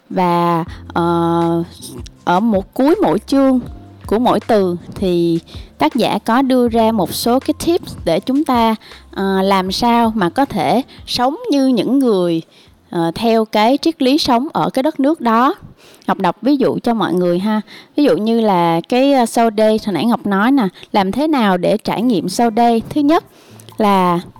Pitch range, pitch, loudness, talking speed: 190-260 Hz, 225 Hz, -15 LUFS, 185 wpm